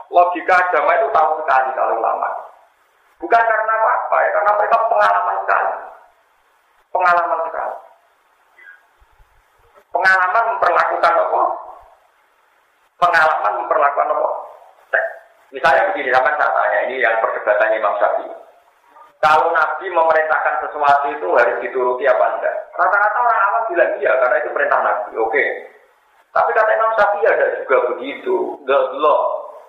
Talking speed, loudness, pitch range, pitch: 125 wpm, -16 LUFS, 155-230 Hz, 195 Hz